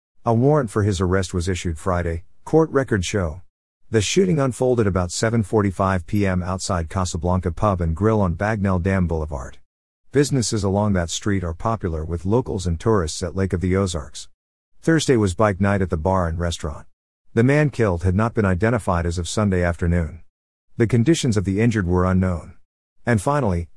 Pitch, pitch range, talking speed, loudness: 95 Hz, 85-110 Hz, 175 wpm, -21 LUFS